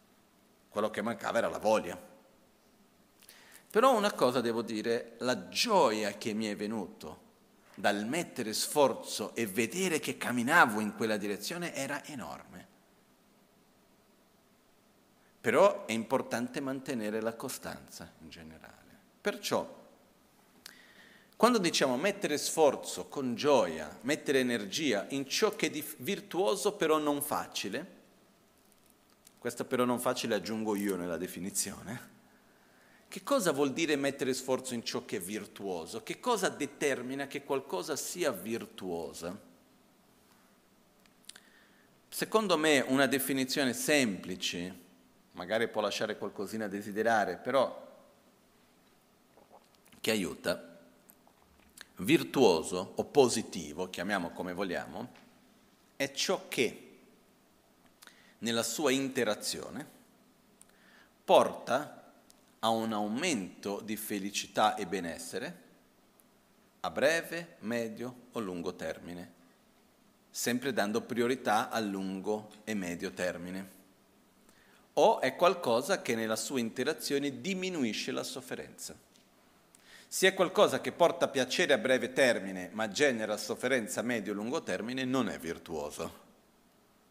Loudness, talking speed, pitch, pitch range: -32 LUFS, 110 wpm, 125 Hz, 105-150 Hz